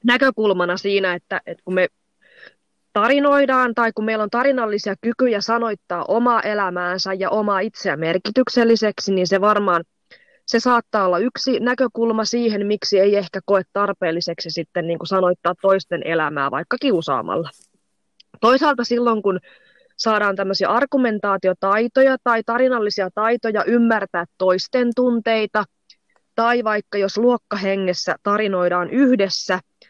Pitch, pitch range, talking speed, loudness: 210 Hz, 185-235 Hz, 120 wpm, -19 LUFS